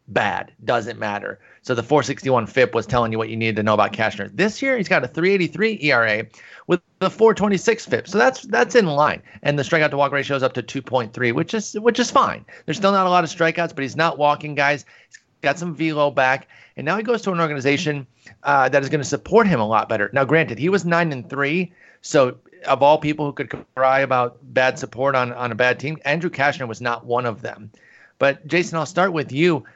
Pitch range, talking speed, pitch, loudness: 125-175 Hz, 235 wpm, 145 Hz, -20 LUFS